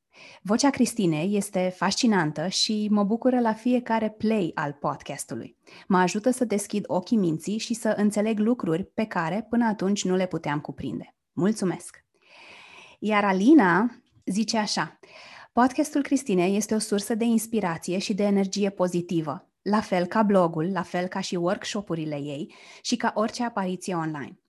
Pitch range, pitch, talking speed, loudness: 180-225 Hz, 205 Hz, 150 wpm, -25 LUFS